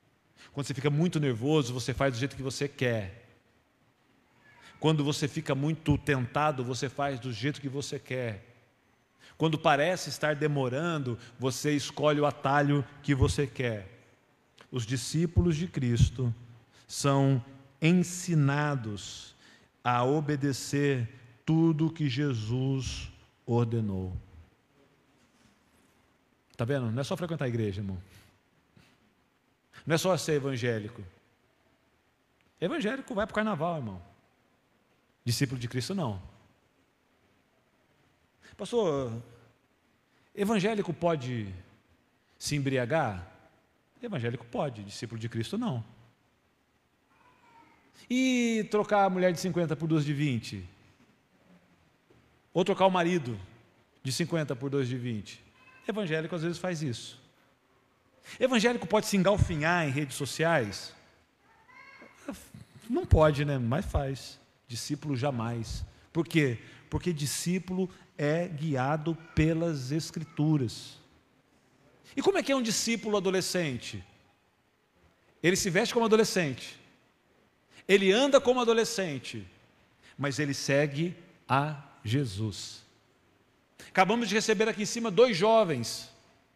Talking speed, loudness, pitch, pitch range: 110 wpm, -29 LUFS, 140 Hz, 120-165 Hz